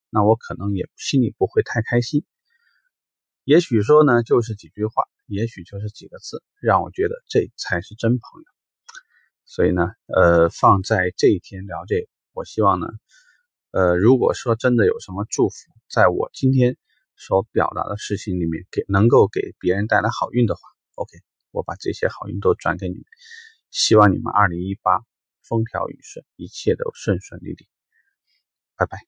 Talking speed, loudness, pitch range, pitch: 250 characters per minute, -20 LUFS, 95-165 Hz, 115 Hz